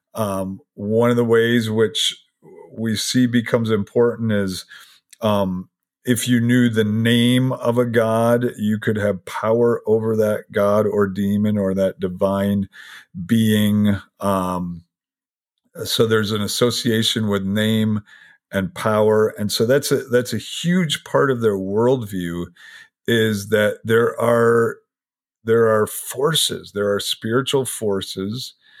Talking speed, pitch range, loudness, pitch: 135 wpm, 100-120 Hz, -19 LUFS, 110 Hz